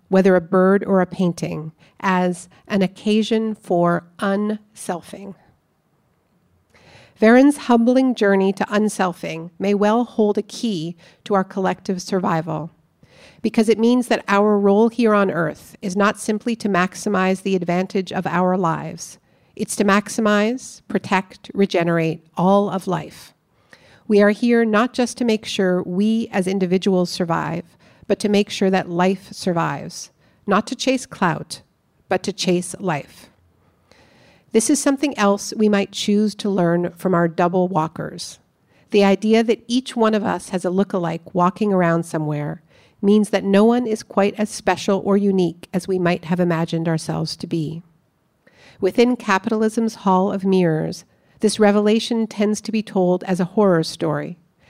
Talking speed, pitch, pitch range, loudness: 150 wpm, 195 Hz, 180-215 Hz, -19 LUFS